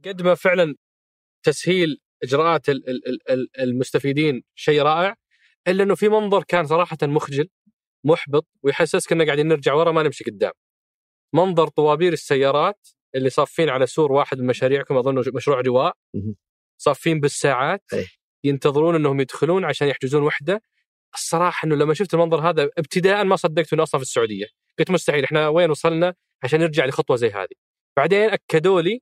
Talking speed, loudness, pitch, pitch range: 155 wpm, -20 LUFS, 155 Hz, 140-175 Hz